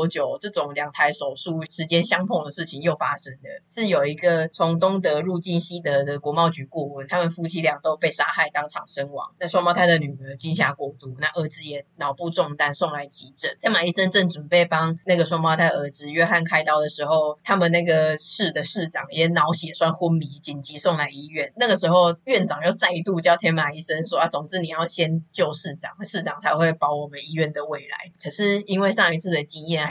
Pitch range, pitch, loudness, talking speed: 150-175 Hz, 165 Hz, -22 LUFS, 320 characters per minute